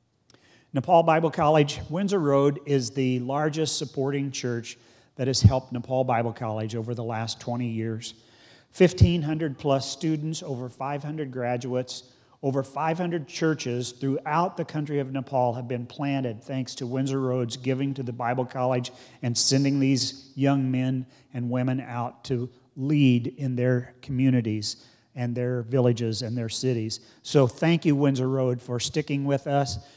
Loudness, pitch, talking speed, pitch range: -26 LUFS, 130 Hz, 150 wpm, 120-140 Hz